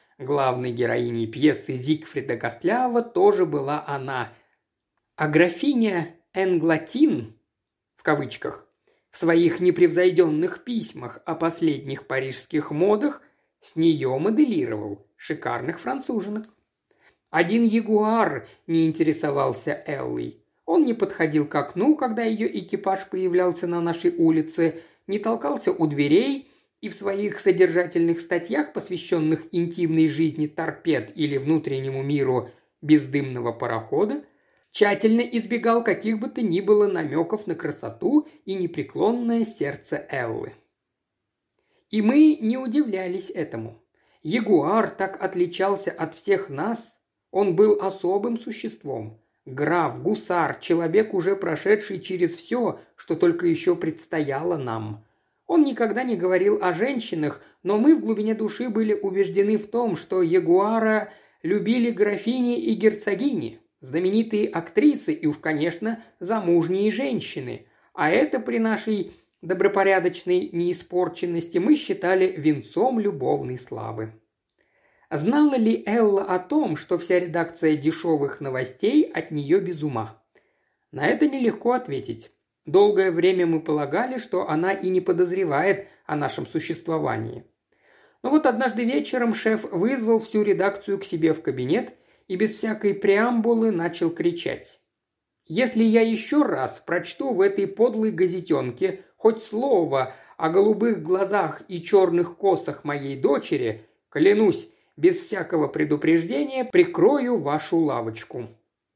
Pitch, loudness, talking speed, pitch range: 190 Hz, -23 LUFS, 120 wpm, 160-225 Hz